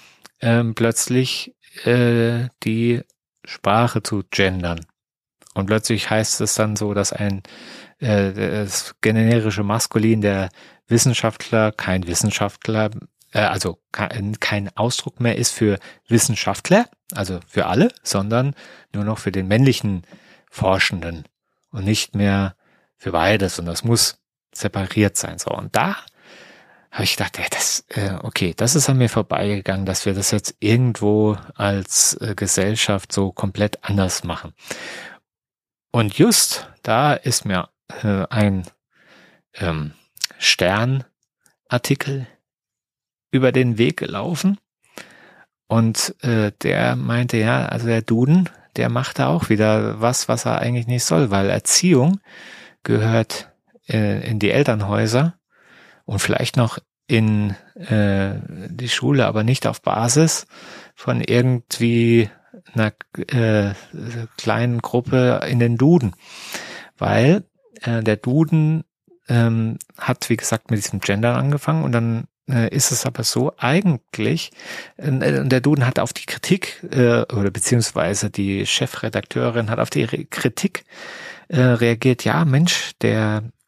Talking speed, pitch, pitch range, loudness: 125 wpm, 115 Hz, 100-125 Hz, -19 LUFS